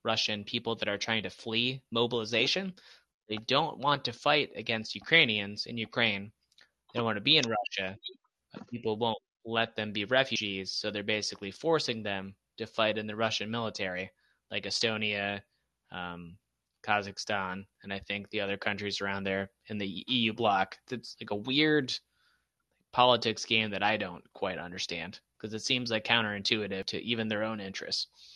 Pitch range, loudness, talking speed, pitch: 100-115 Hz, -30 LUFS, 165 wpm, 110 Hz